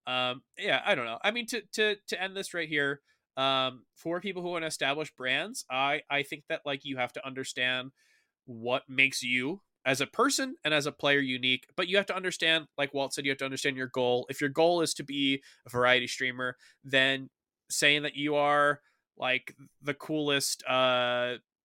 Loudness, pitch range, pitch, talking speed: -29 LUFS, 130-160 Hz, 140 Hz, 205 wpm